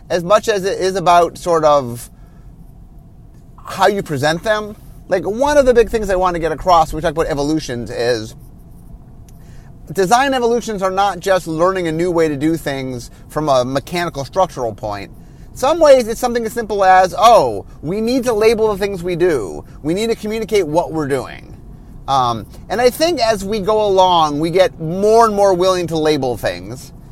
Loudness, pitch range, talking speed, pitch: -15 LUFS, 150-215 Hz, 190 wpm, 180 Hz